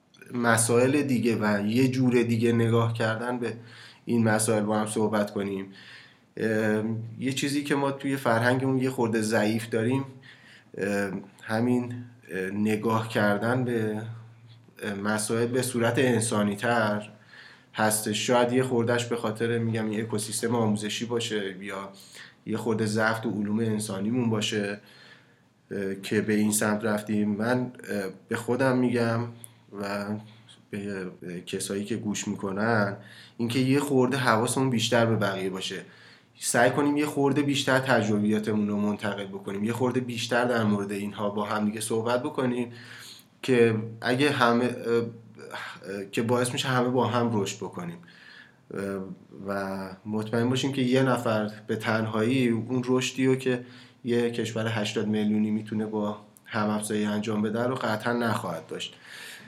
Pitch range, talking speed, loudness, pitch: 105-120 Hz, 135 wpm, -27 LUFS, 115 Hz